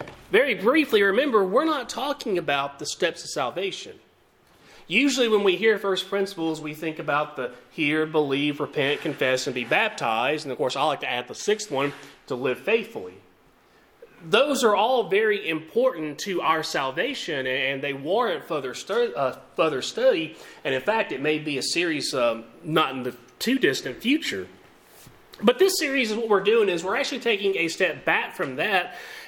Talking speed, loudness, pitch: 180 wpm, -24 LUFS, 200 Hz